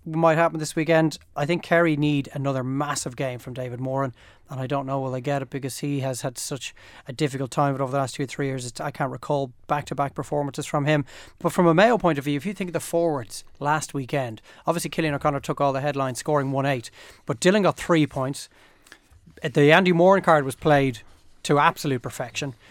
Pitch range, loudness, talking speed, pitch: 135-160 Hz, -24 LUFS, 225 wpm, 145 Hz